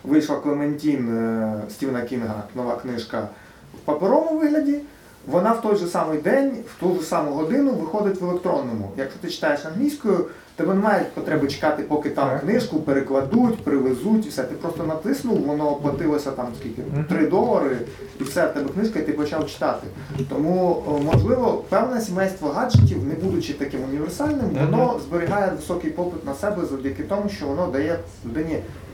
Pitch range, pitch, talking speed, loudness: 140-200 Hz, 155 Hz, 160 wpm, -23 LUFS